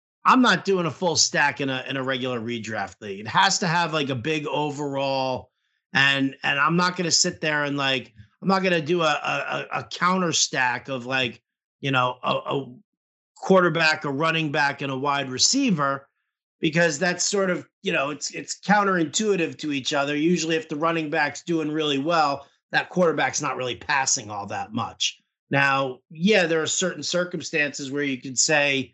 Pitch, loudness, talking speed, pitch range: 150 Hz, -23 LUFS, 195 wpm, 135-175 Hz